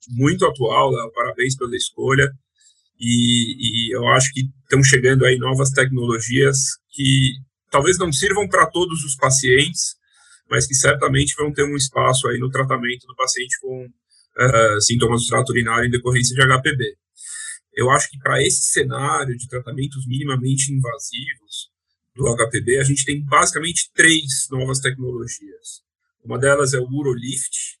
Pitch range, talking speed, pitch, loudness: 125-140 Hz, 145 wpm, 130 Hz, -18 LUFS